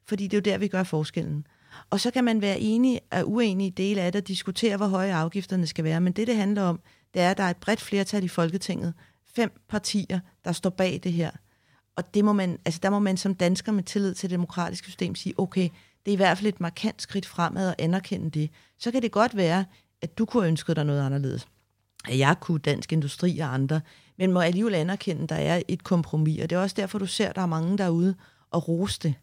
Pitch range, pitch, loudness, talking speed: 165-200 Hz, 185 Hz, -26 LUFS, 250 wpm